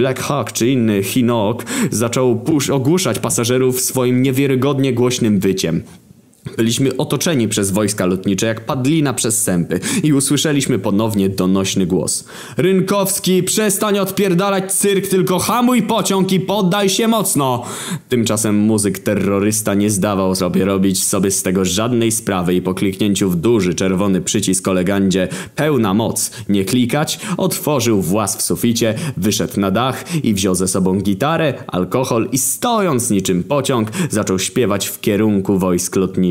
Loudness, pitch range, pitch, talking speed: -16 LUFS, 100-150 Hz, 115 Hz, 140 wpm